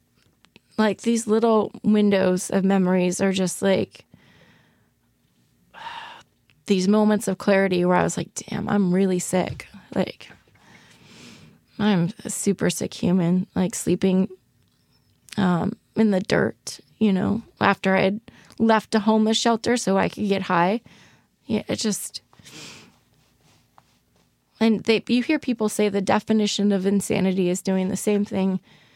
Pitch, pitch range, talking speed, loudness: 200 Hz, 190-215 Hz, 135 wpm, -22 LUFS